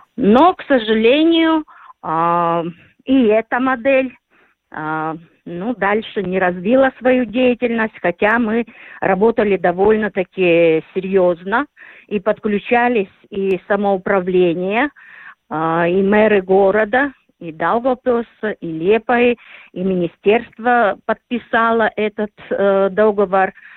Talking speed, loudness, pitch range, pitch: 85 wpm, -16 LUFS, 185-240 Hz, 210 Hz